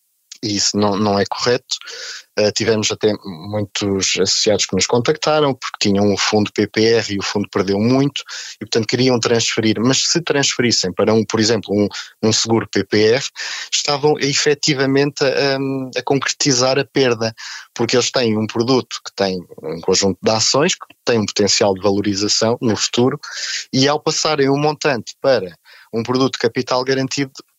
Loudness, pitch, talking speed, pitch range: -17 LUFS, 115 Hz, 170 wpm, 105-135 Hz